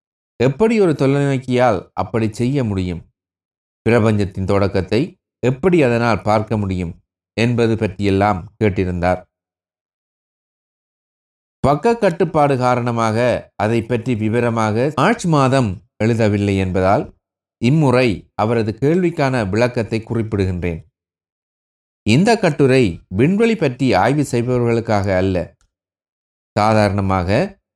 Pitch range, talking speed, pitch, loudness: 95-125 Hz, 80 wpm, 110 Hz, -17 LUFS